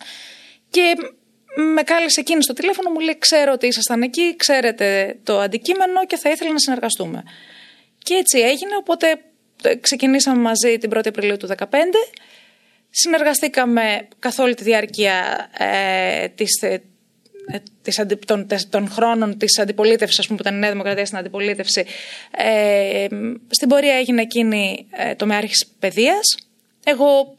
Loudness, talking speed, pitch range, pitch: -17 LUFS, 145 wpm, 210-295 Hz, 230 Hz